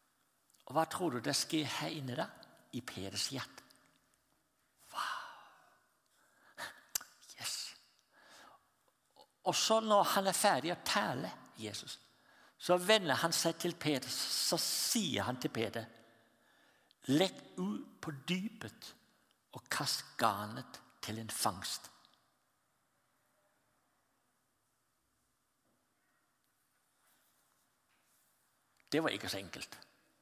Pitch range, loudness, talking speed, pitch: 125-180 Hz, -36 LUFS, 95 wpm, 160 Hz